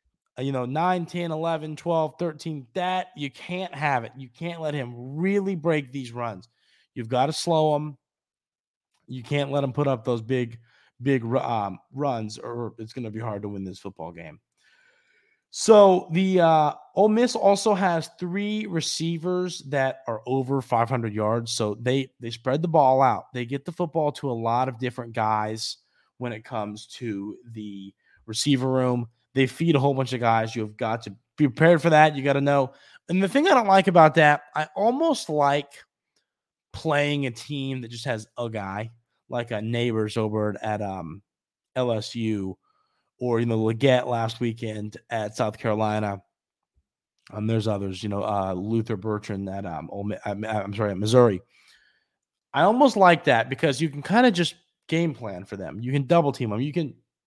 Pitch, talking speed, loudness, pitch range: 130 Hz, 185 wpm, -24 LUFS, 110-155 Hz